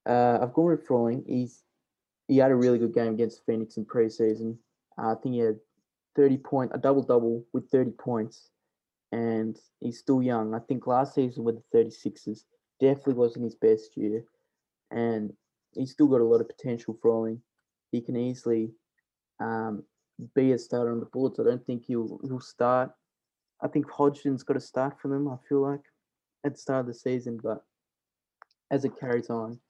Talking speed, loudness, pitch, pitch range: 185 wpm, -28 LUFS, 120 Hz, 115-135 Hz